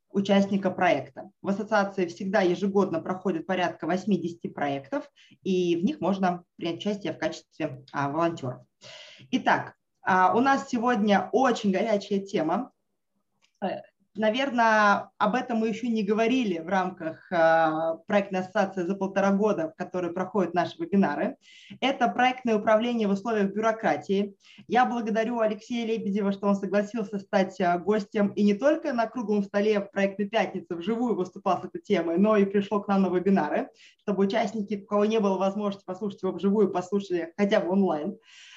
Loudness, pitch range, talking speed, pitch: -26 LUFS, 185-215 Hz, 150 wpm, 200 Hz